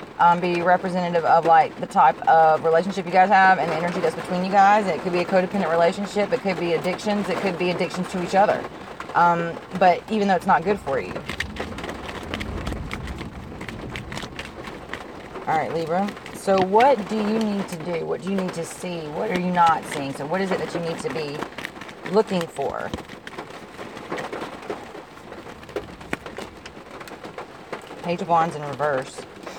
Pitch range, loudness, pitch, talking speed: 170-195 Hz, -22 LUFS, 180 Hz, 165 wpm